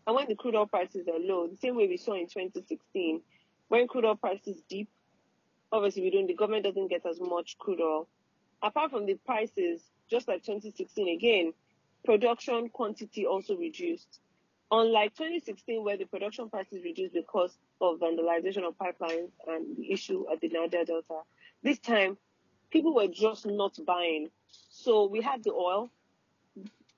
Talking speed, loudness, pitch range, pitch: 165 wpm, -31 LUFS, 180-245 Hz, 205 Hz